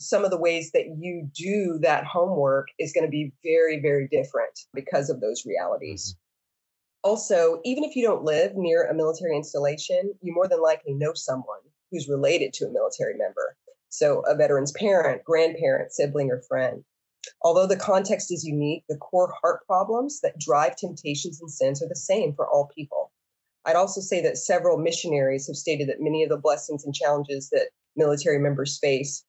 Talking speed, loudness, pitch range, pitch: 180 wpm, -25 LUFS, 145-195 Hz, 165 Hz